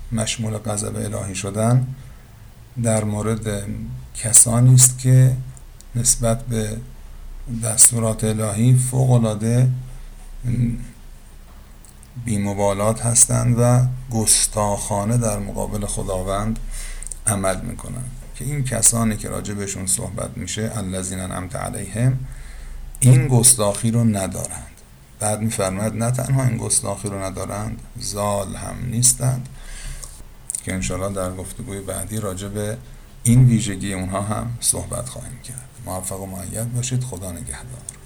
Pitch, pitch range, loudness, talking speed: 110 Hz, 100-120 Hz, -19 LUFS, 110 wpm